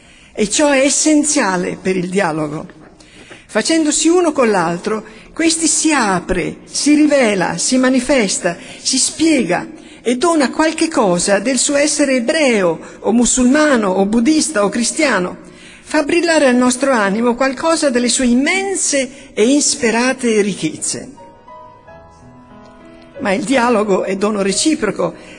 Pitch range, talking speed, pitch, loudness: 200-295 Hz, 125 wpm, 255 Hz, -14 LUFS